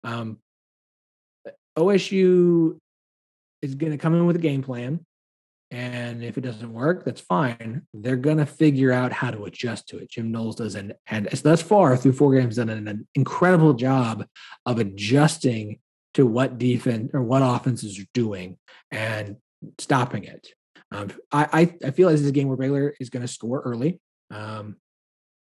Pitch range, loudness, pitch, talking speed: 115-150 Hz, -22 LUFS, 130 Hz, 175 wpm